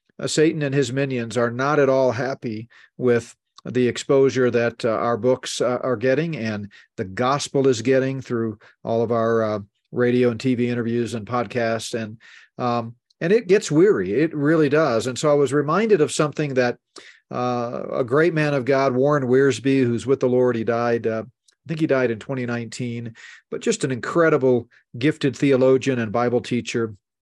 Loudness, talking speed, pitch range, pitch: -21 LUFS, 175 wpm, 120-140 Hz, 125 Hz